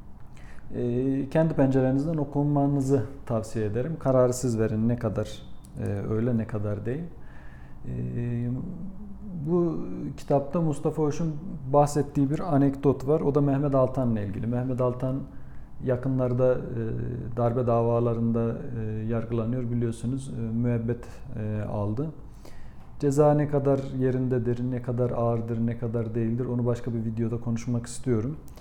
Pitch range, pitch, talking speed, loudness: 115-140 Hz, 125 Hz, 125 wpm, -27 LUFS